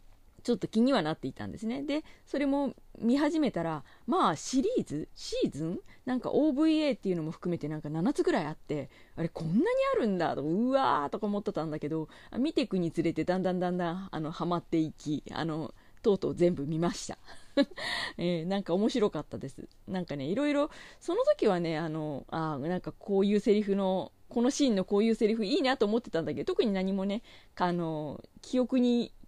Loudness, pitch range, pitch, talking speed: -31 LUFS, 160-250 Hz, 190 Hz, 400 characters per minute